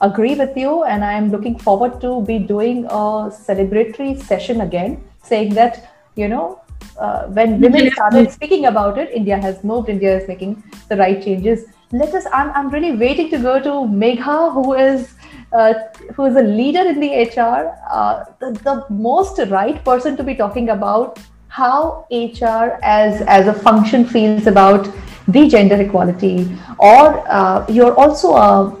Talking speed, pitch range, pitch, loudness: 170 wpm, 210-270 Hz, 230 Hz, -14 LUFS